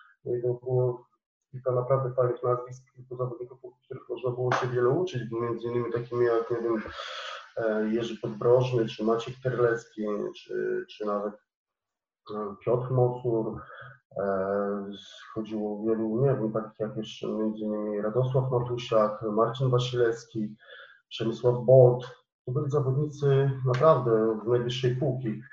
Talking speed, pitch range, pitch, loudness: 125 wpm, 110-125 Hz, 120 Hz, -28 LUFS